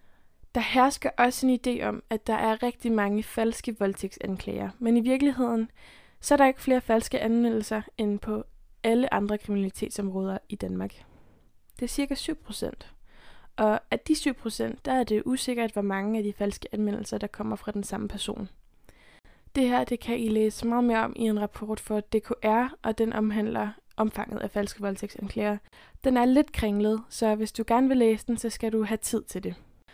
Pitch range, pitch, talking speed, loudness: 210-240 Hz, 220 Hz, 190 wpm, -27 LUFS